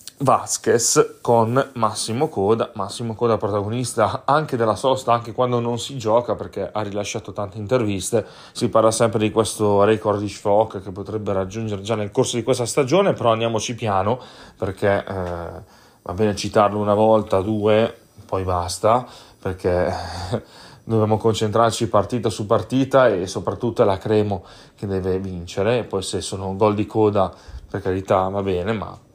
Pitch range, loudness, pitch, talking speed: 100-115 Hz, -21 LUFS, 110 Hz, 155 wpm